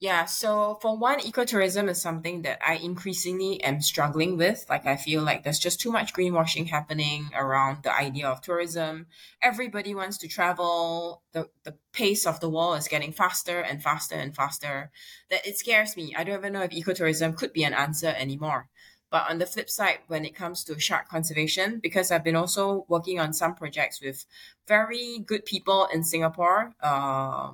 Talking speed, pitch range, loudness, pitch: 185 wpm, 155-190 Hz, -26 LUFS, 170 Hz